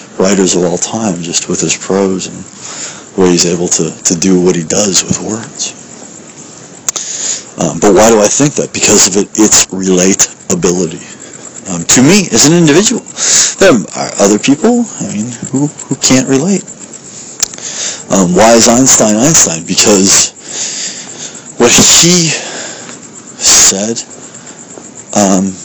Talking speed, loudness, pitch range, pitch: 135 wpm, -8 LUFS, 95-145 Hz, 105 Hz